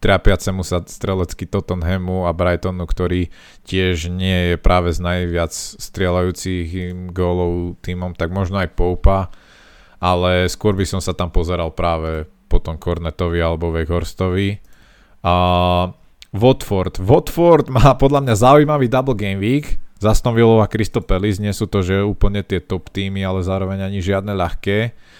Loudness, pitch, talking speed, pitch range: -18 LUFS, 95 Hz, 140 wpm, 90-100 Hz